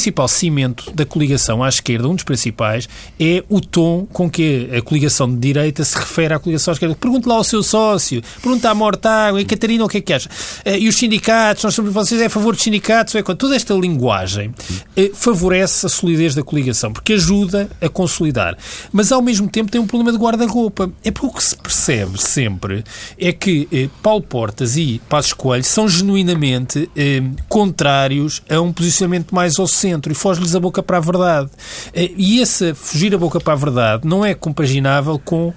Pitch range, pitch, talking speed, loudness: 140-210 Hz, 175 Hz, 190 wpm, -15 LUFS